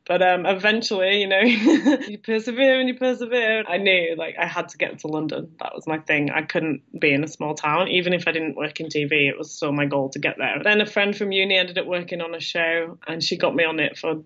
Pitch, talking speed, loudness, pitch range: 175 Hz, 265 wpm, -21 LUFS, 155-205 Hz